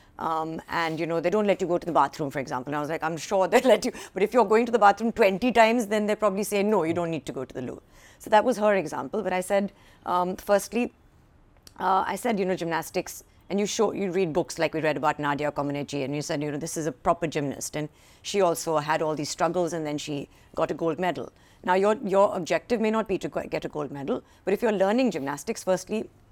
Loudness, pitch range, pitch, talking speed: -26 LUFS, 155-205 Hz, 175 Hz, 260 wpm